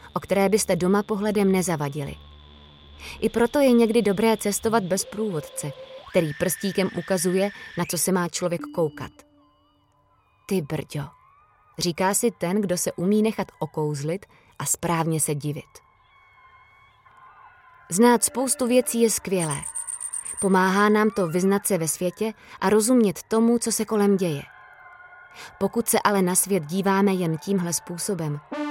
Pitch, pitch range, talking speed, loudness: 195 Hz, 175-230 Hz, 135 wpm, -23 LUFS